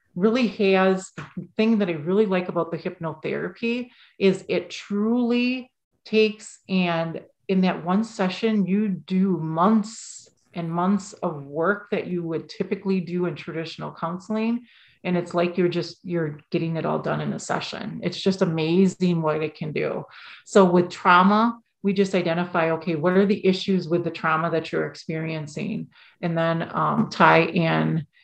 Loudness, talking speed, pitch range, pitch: -23 LUFS, 160 wpm, 165-205 Hz, 180 Hz